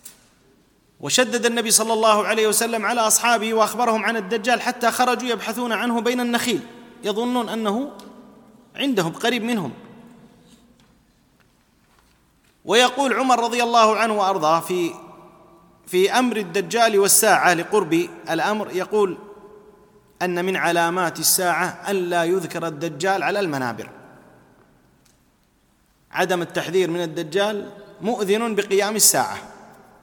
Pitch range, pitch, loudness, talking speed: 185-235 Hz, 210 Hz, -20 LUFS, 105 wpm